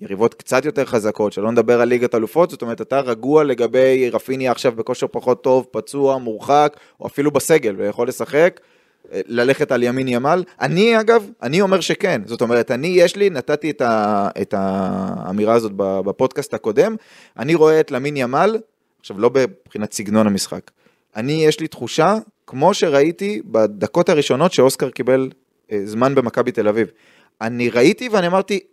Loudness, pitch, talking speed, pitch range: -17 LUFS, 130 Hz, 160 wpm, 115-165 Hz